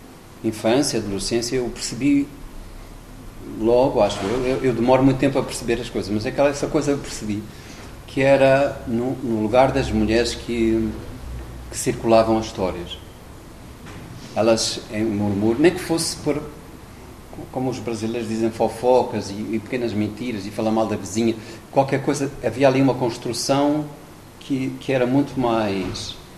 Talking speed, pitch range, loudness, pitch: 150 wpm, 110-135 Hz, -21 LUFS, 120 Hz